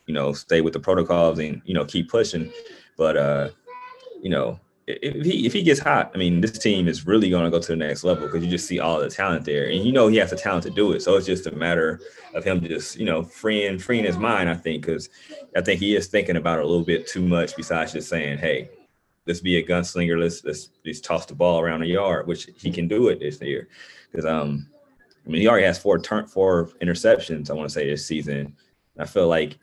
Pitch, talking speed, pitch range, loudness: 85 Hz, 255 wpm, 80-95 Hz, -22 LUFS